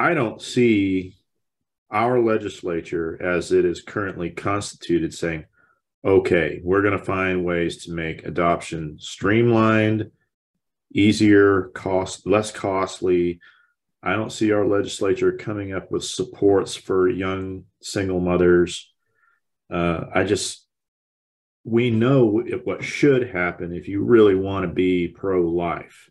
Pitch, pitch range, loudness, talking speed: 95 Hz, 90-110 Hz, -21 LUFS, 125 wpm